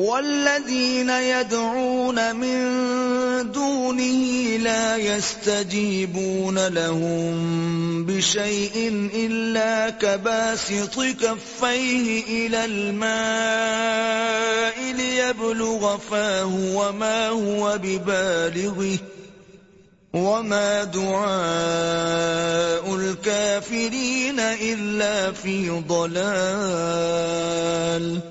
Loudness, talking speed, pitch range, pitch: -22 LUFS, 50 wpm, 190-230 Hz, 210 Hz